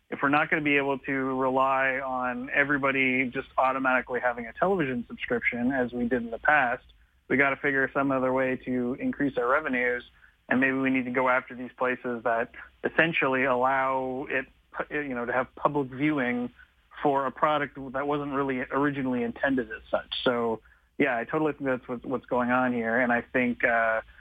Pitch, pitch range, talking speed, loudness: 130 Hz, 125-140 Hz, 190 wpm, -27 LUFS